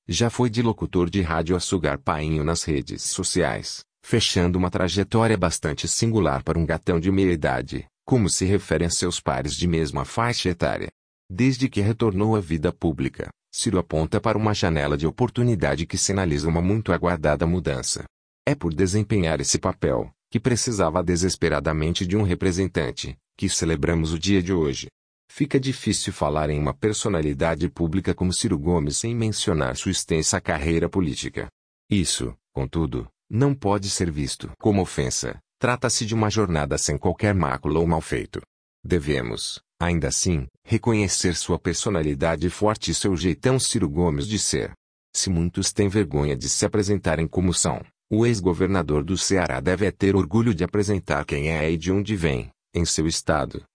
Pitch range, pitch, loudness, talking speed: 80-105 Hz, 90 Hz, -23 LUFS, 160 wpm